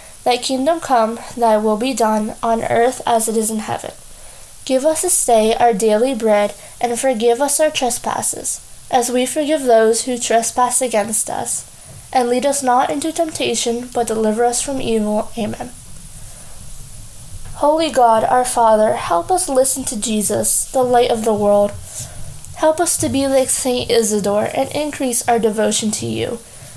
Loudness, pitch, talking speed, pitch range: -16 LUFS, 235 Hz, 165 wpm, 215-260 Hz